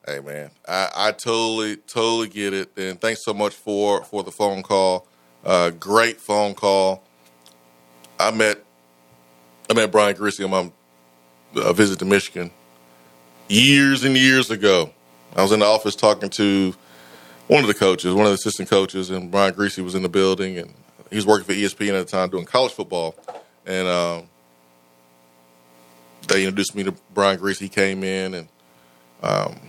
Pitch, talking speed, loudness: 95 Hz, 170 wpm, -20 LUFS